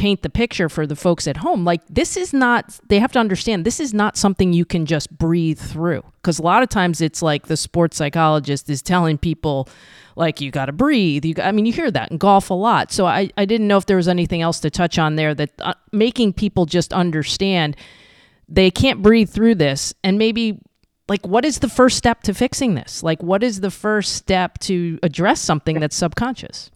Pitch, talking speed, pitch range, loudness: 180 Hz, 225 wpm, 160-215 Hz, -18 LUFS